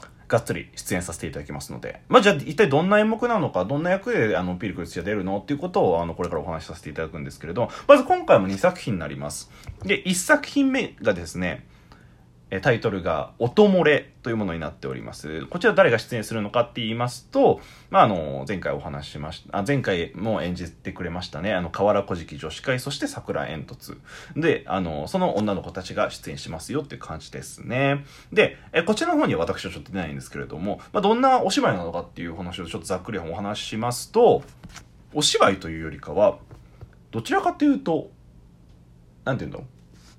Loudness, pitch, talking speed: -23 LUFS, 100 Hz, 410 characters per minute